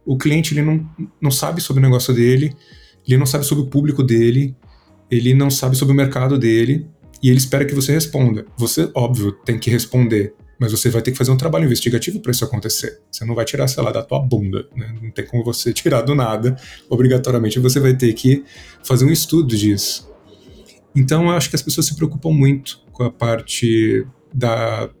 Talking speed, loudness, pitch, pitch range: 205 wpm, -17 LUFS, 130 Hz, 115-140 Hz